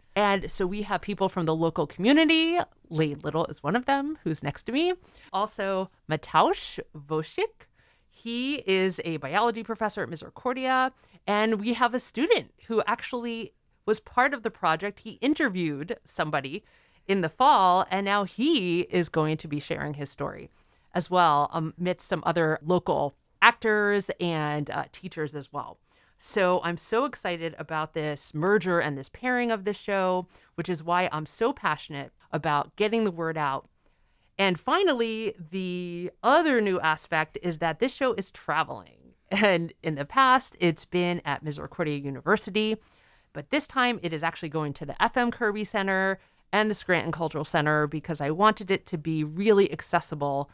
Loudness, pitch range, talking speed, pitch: -27 LUFS, 160-220 Hz, 165 wpm, 180 Hz